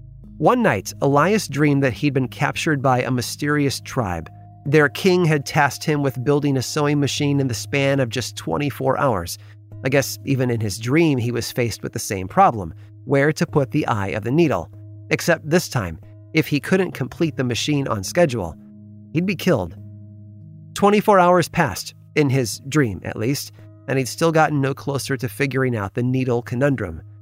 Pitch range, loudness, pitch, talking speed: 105-145 Hz, -20 LUFS, 130 Hz, 185 wpm